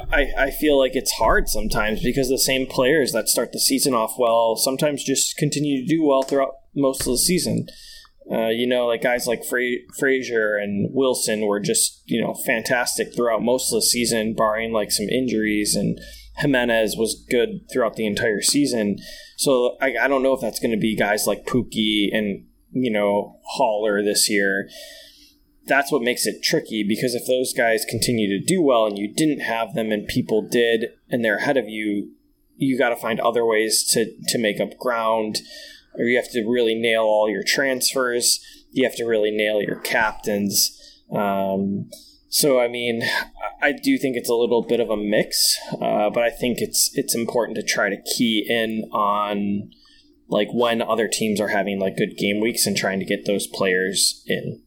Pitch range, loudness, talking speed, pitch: 105-135 Hz, -21 LUFS, 195 wpm, 120 Hz